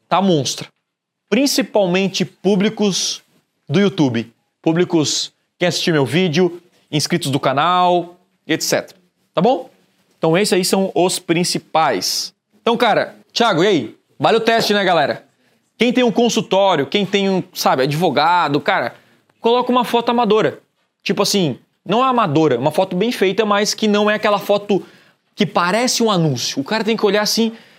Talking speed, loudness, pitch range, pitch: 155 wpm, -17 LUFS, 175-215 Hz, 195 Hz